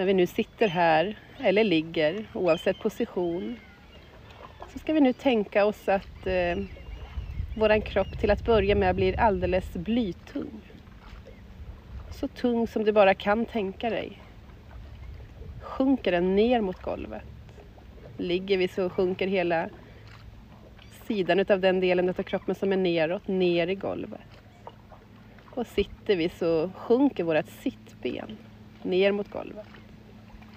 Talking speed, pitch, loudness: 130 wpm, 180 Hz, -26 LUFS